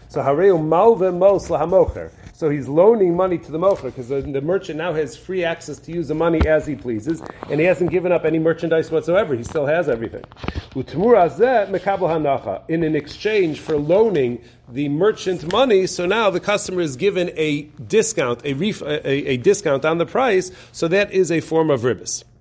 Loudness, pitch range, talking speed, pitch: -19 LUFS, 145-185 Hz, 175 wpm, 165 Hz